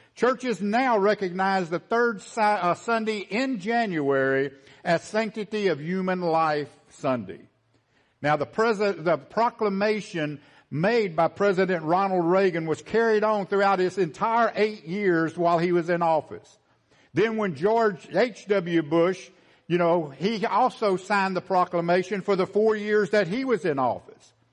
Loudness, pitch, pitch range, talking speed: -24 LUFS, 195 Hz, 170-215 Hz, 145 wpm